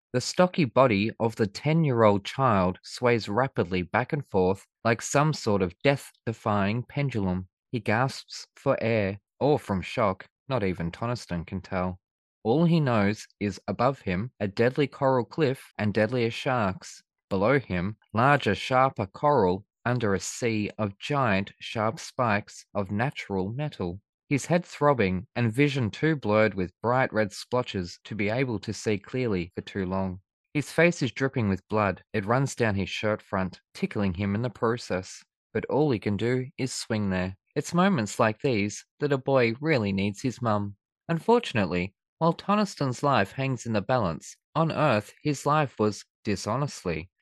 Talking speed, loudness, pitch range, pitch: 165 wpm, -27 LUFS, 100-135 Hz, 115 Hz